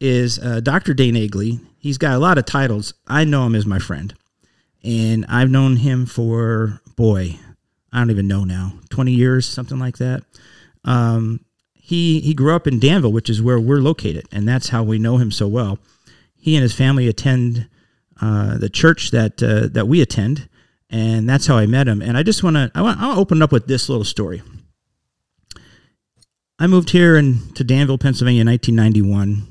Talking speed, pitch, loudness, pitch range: 195 wpm, 120 Hz, -17 LUFS, 110-135 Hz